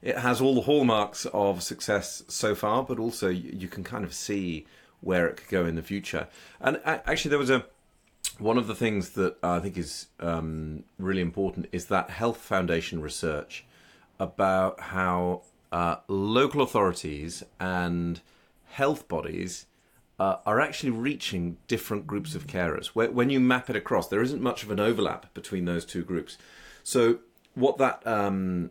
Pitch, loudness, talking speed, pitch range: 95 Hz, -28 LUFS, 165 wpm, 85-115 Hz